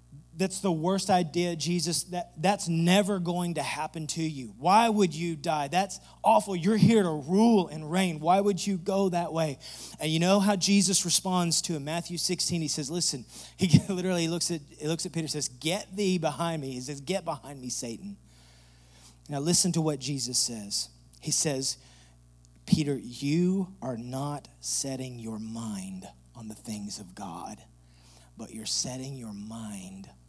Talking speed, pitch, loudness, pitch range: 175 wpm, 155 Hz, -28 LUFS, 115-180 Hz